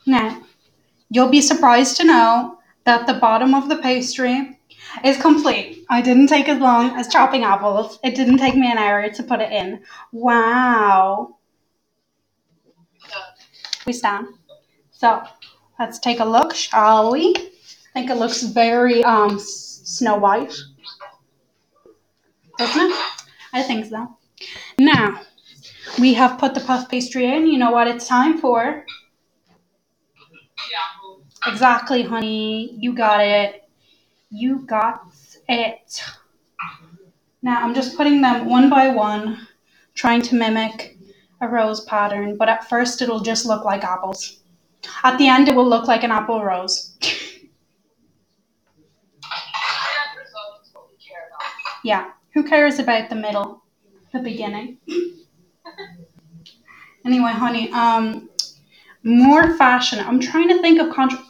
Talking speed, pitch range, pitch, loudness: 125 wpm, 215-265 Hz, 240 Hz, -17 LUFS